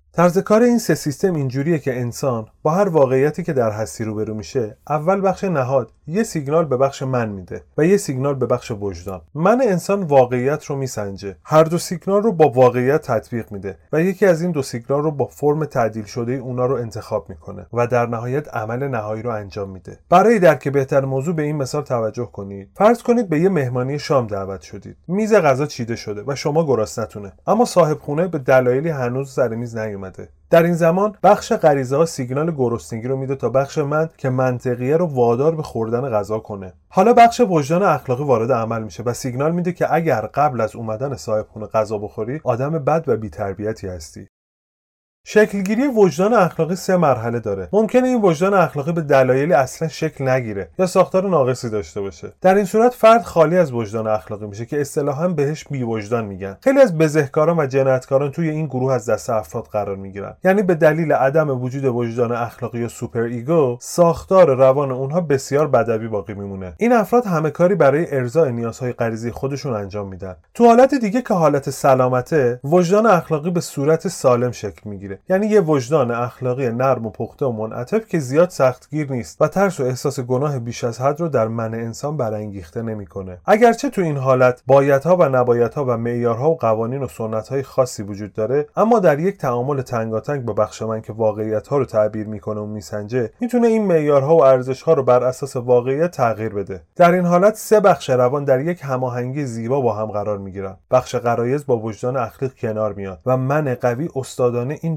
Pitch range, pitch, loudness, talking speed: 115-160 Hz, 130 Hz, -18 LUFS, 190 wpm